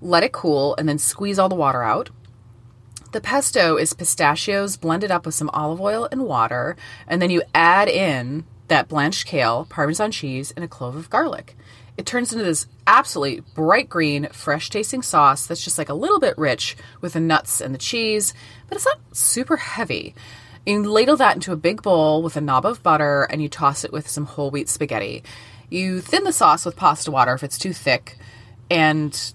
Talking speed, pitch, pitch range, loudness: 200 wpm, 155 Hz, 135-190 Hz, -19 LUFS